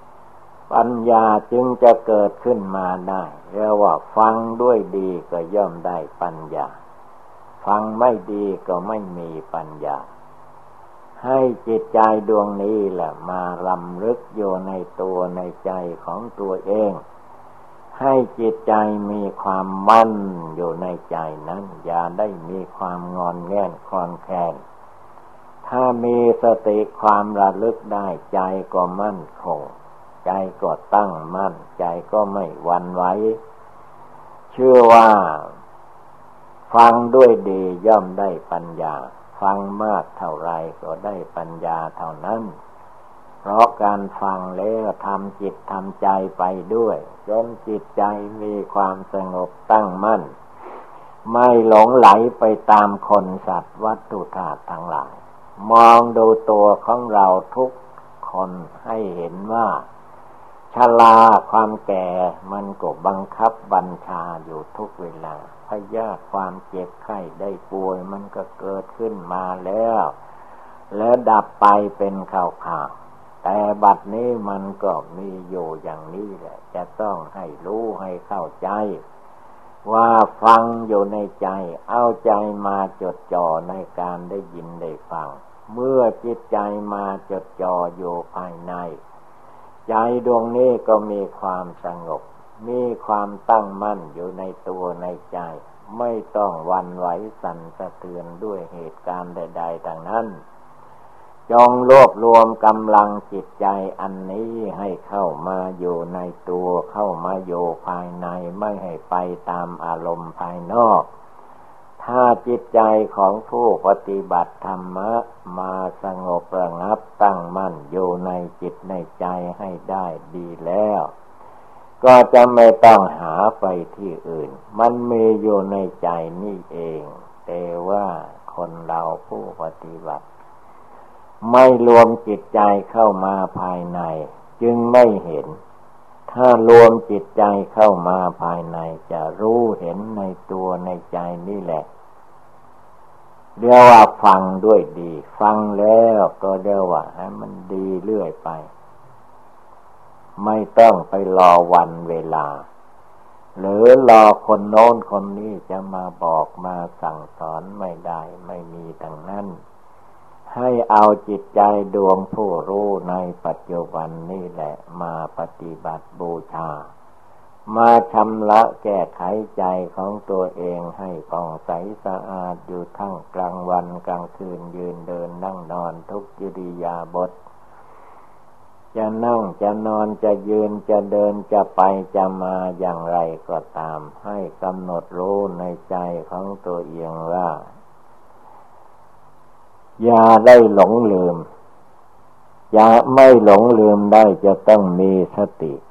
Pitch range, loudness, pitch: 90-110 Hz, -17 LUFS, 95 Hz